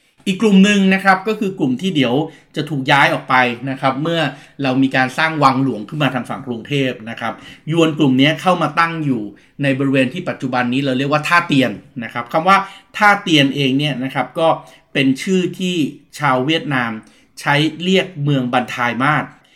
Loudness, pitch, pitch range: -16 LUFS, 145 Hz, 130-165 Hz